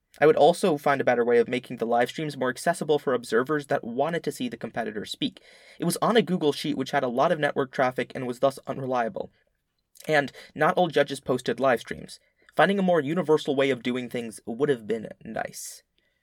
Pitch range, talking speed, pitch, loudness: 125-155 Hz, 220 wpm, 140 Hz, -25 LUFS